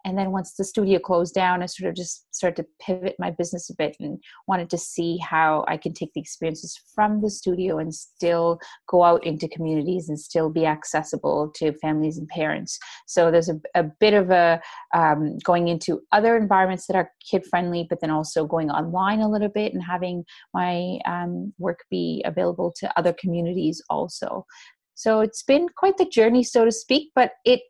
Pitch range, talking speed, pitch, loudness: 165-200 Hz, 195 wpm, 175 Hz, -23 LUFS